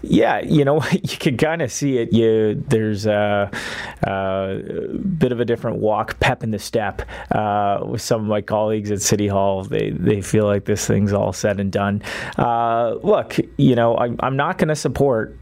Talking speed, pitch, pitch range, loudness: 200 wpm, 110 Hz, 105-130 Hz, -19 LUFS